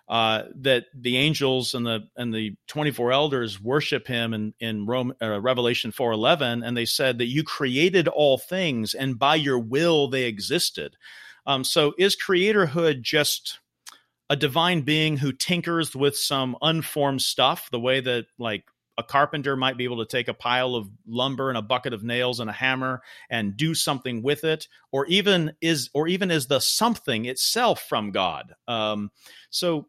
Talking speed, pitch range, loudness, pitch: 180 wpm, 120-150 Hz, -23 LUFS, 130 Hz